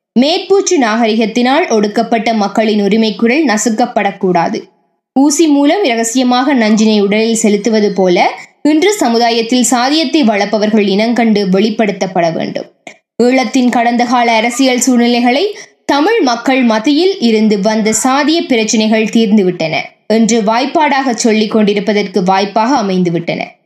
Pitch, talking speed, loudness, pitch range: 230 Hz, 100 wpm, -11 LUFS, 215-260 Hz